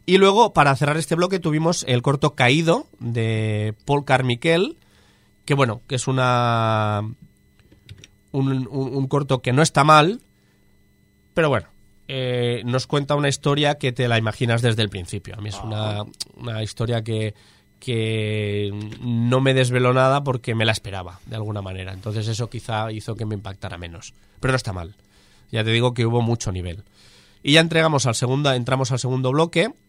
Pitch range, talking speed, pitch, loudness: 110-140 Hz, 175 wpm, 120 Hz, -21 LUFS